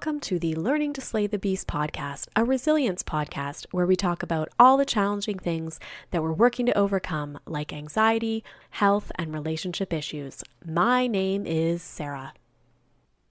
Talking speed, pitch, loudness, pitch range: 160 wpm, 175 Hz, -26 LUFS, 150-210 Hz